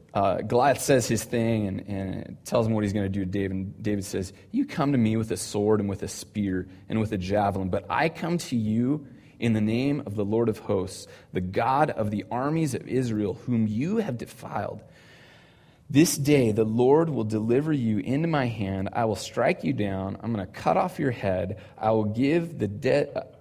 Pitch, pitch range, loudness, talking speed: 110 Hz, 100-130 Hz, -26 LUFS, 220 wpm